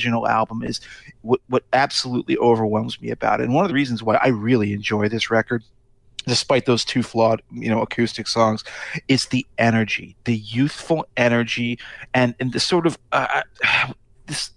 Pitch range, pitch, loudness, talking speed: 110-125 Hz, 120 Hz, -20 LUFS, 170 wpm